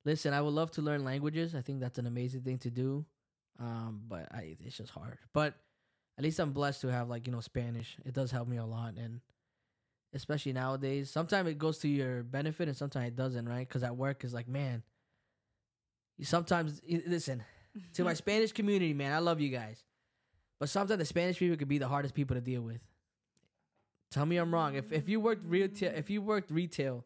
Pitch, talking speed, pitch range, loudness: 135 Hz, 215 wpm, 120-160 Hz, -35 LUFS